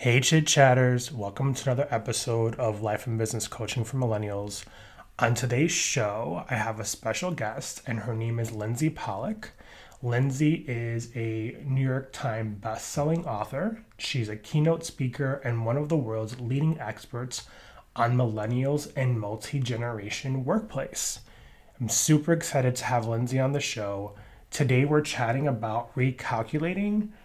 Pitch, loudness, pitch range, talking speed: 125 Hz, -28 LUFS, 115-145 Hz, 150 wpm